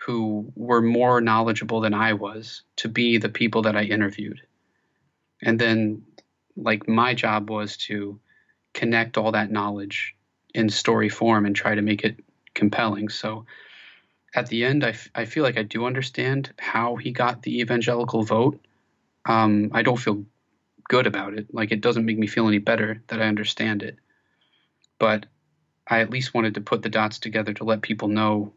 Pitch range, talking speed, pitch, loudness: 105-115 Hz, 180 wpm, 110 Hz, -23 LUFS